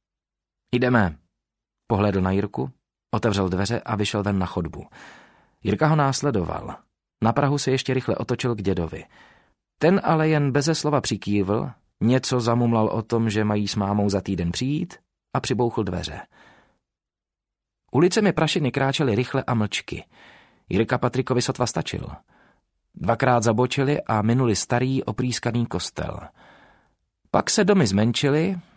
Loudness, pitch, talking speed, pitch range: -23 LUFS, 120 Hz, 135 wpm, 100-135 Hz